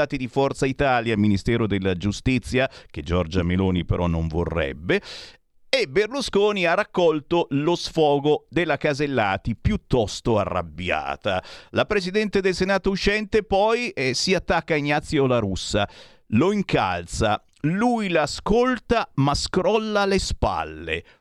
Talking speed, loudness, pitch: 120 wpm, -23 LUFS, 145 Hz